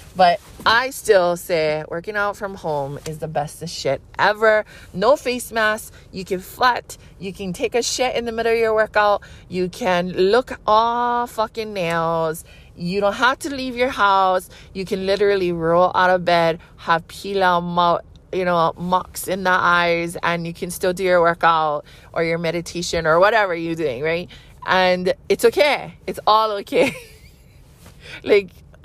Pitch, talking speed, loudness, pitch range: 185 Hz, 170 wpm, -19 LUFS, 170-215 Hz